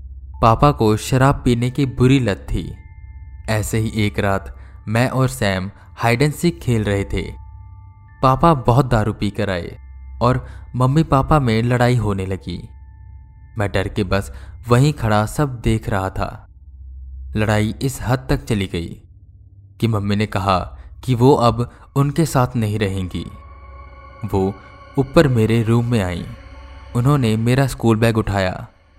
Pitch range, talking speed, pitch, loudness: 95-120 Hz, 150 wpm, 105 Hz, -18 LUFS